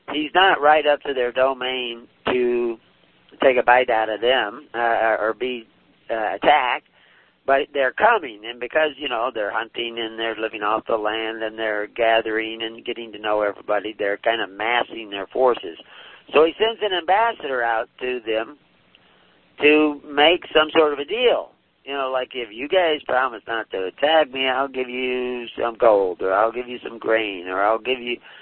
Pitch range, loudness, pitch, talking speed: 110-145 Hz, -21 LUFS, 125 Hz, 190 wpm